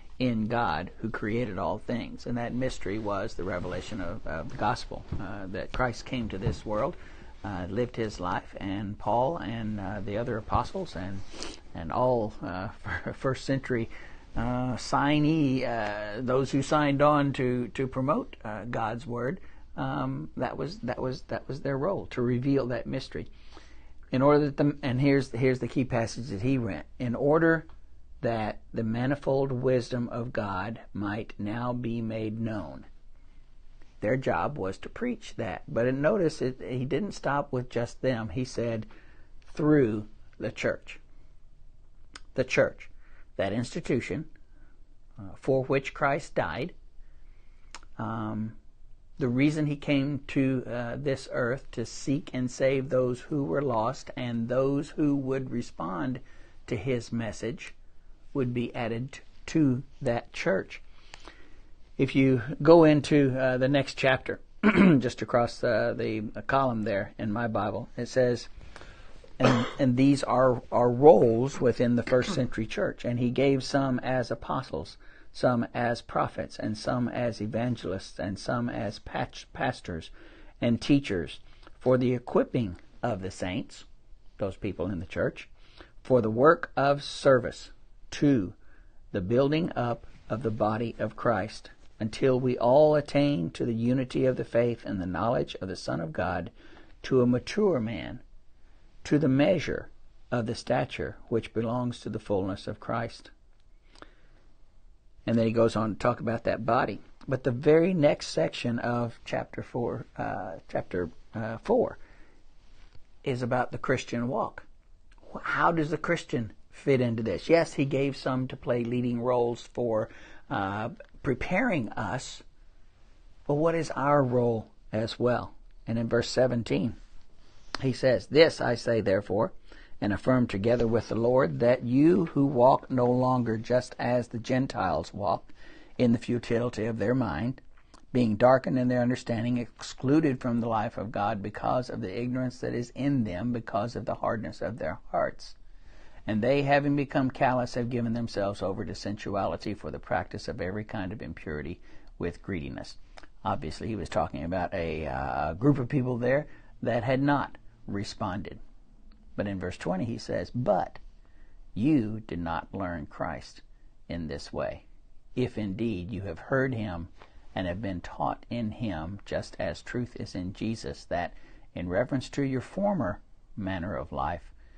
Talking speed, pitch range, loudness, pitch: 155 wpm, 105-130 Hz, -29 LUFS, 120 Hz